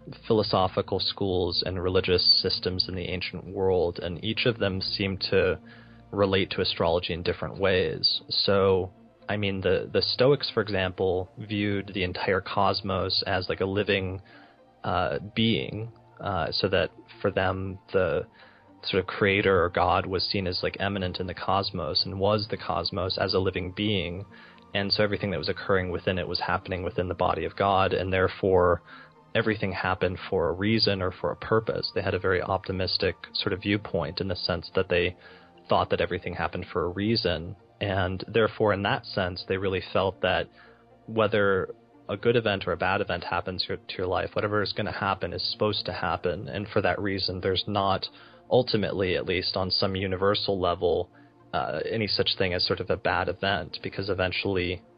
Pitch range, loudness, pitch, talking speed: 90-105 Hz, -27 LUFS, 100 Hz, 180 wpm